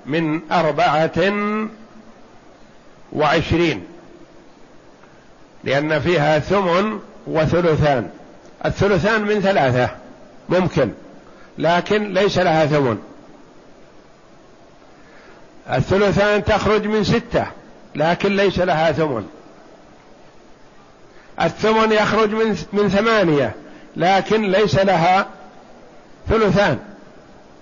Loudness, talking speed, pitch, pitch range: -18 LUFS, 65 wpm, 190 Hz, 155-205 Hz